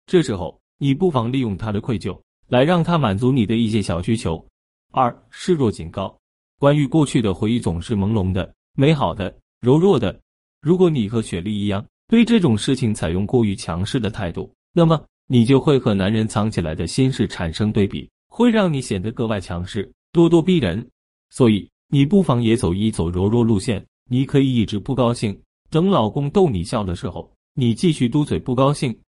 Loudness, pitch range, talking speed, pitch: -19 LUFS, 100-140 Hz, 285 characters per minute, 115 Hz